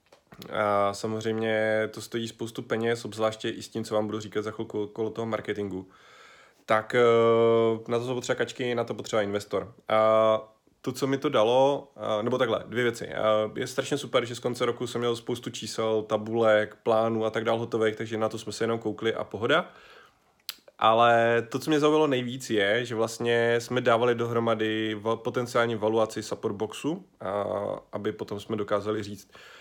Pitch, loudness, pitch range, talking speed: 115 Hz, -27 LUFS, 110-120 Hz, 175 wpm